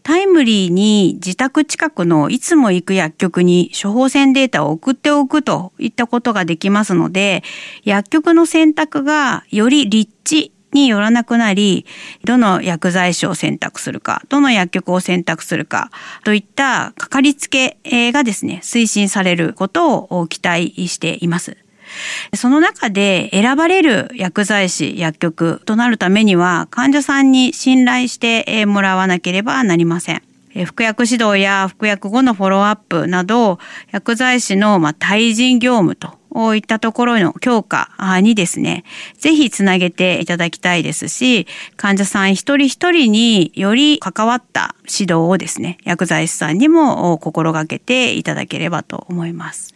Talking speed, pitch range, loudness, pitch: 300 characters per minute, 180-255 Hz, -14 LUFS, 210 Hz